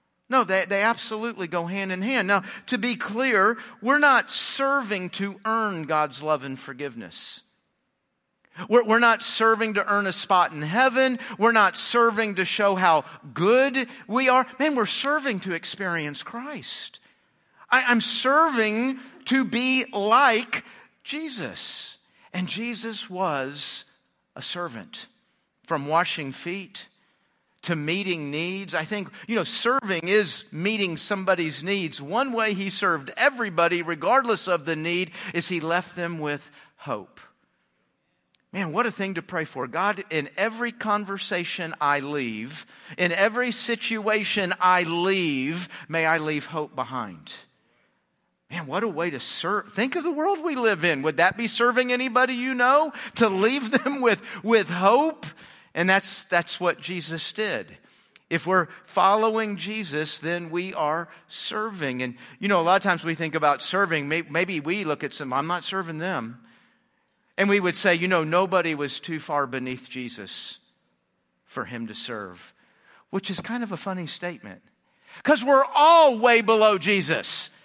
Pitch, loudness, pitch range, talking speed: 195 Hz, -24 LUFS, 165-230 Hz, 155 wpm